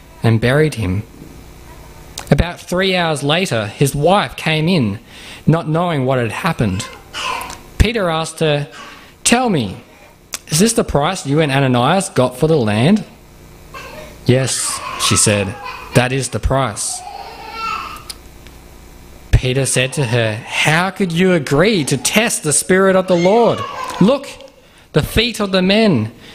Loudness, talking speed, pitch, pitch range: -15 LUFS, 135 wpm, 150 Hz, 120-190 Hz